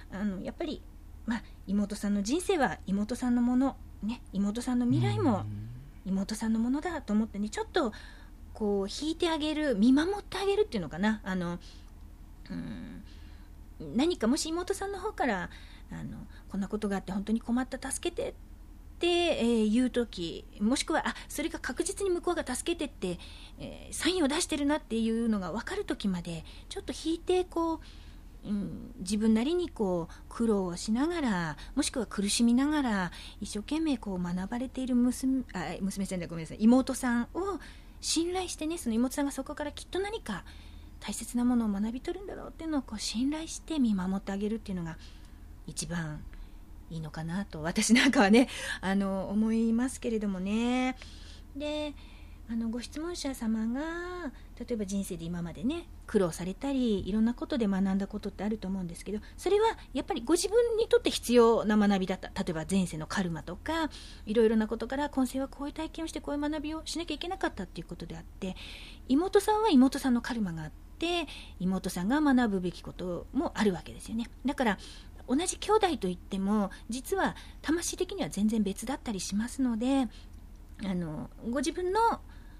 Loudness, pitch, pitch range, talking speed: -31 LUFS, 235 Hz, 195-300 Hz, 345 characters per minute